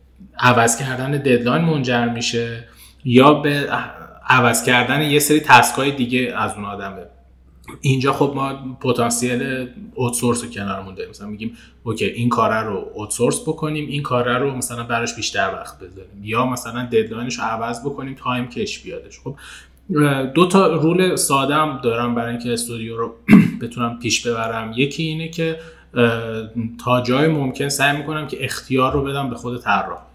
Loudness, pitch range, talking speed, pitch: -18 LUFS, 115-140 Hz, 155 wpm, 125 Hz